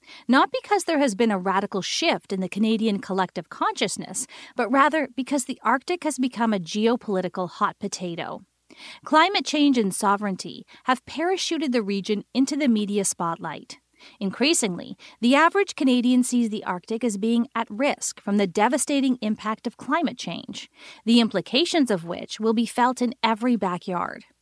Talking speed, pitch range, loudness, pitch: 155 wpm, 205-280 Hz, -23 LUFS, 235 Hz